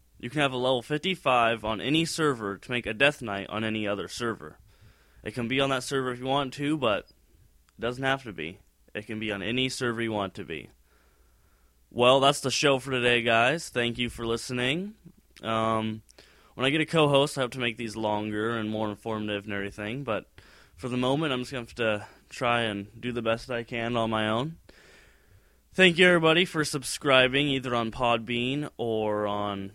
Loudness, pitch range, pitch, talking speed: -27 LUFS, 110-135 Hz, 120 Hz, 205 wpm